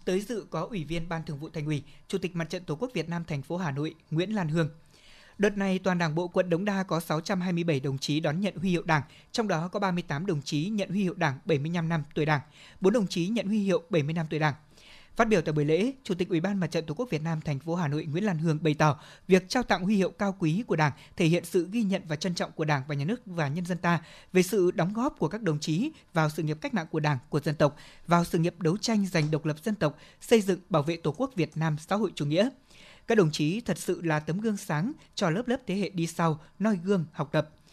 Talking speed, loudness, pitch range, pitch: 280 wpm, -29 LUFS, 155-195 Hz, 170 Hz